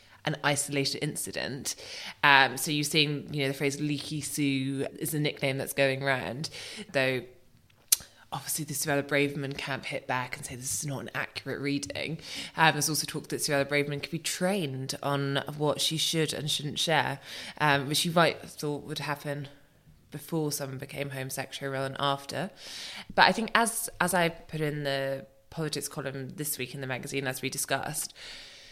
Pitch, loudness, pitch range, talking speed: 145 Hz, -29 LUFS, 135-150 Hz, 180 wpm